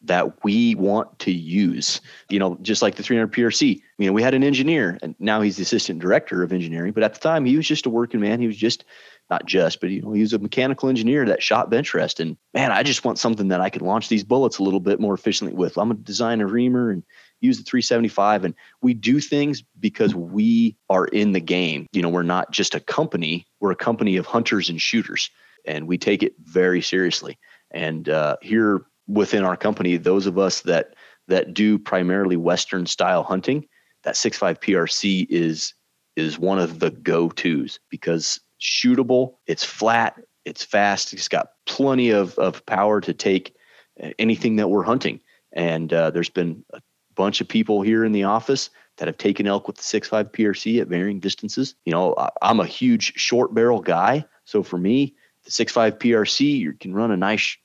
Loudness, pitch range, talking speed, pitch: -21 LUFS, 90-120 Hz, 205 wpm, 105 Hz